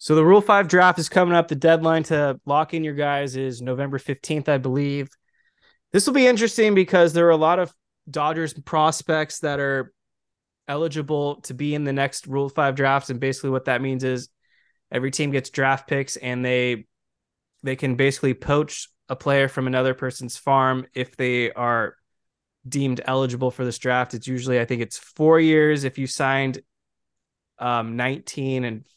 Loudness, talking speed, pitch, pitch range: -21 LUFS, 180 wpm, 135 Hz, 130-155 Hz